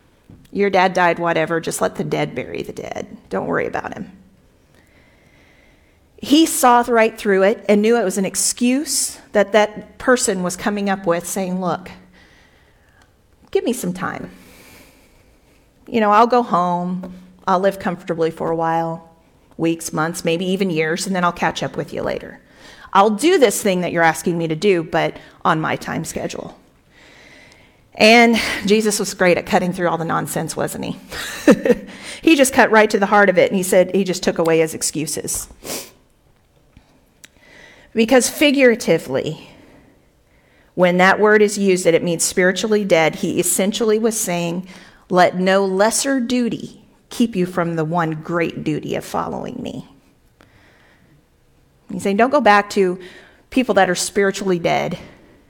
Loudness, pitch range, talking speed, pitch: -17 LUFS, 170-215 Hz, 160 wpm, 190 Hz